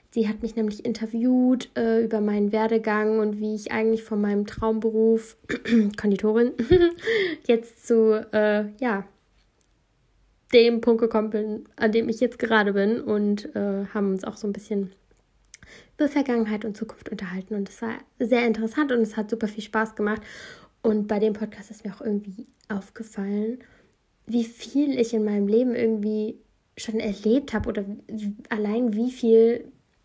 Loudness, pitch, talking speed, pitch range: -24 LUFS, 220 Hz, 160 wpm, 210-235 Hz